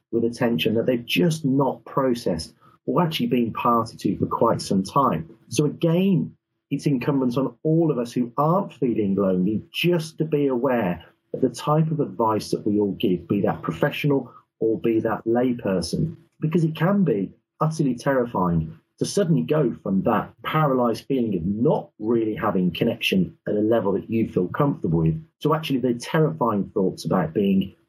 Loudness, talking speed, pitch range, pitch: -23 LUFS, 175 wpm, 110-155 Hz, 125 Hz